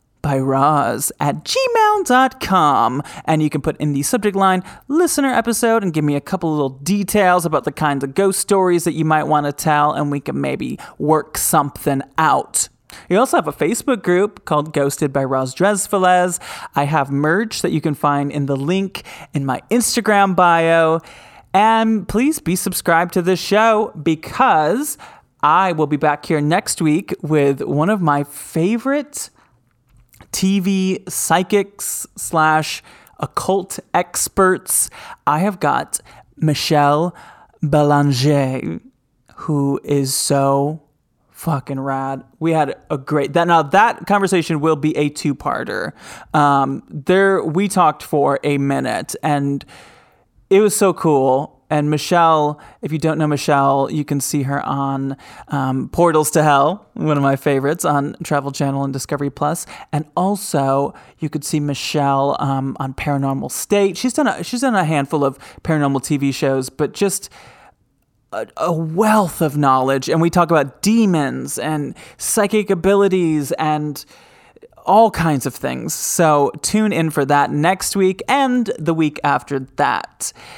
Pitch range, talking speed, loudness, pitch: 145-190 Hz, 150 wpm, -17 LUFS, 155 Hz